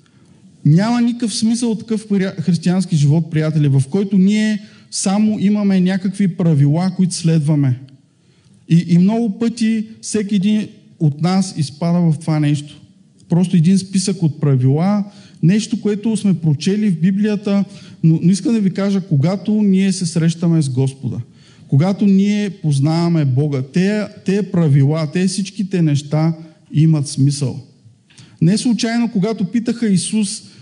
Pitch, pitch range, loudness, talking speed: 185 Hz, 155-205 Hz, -16 LUFS, 135 wpm